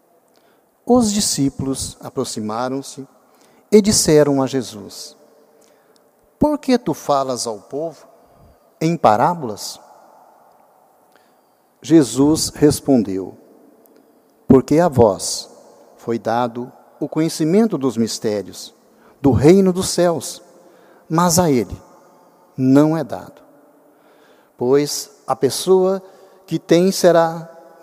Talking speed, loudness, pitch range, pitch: 90 wpm, -17 LUFS, 130-175 Hz, 155 Hz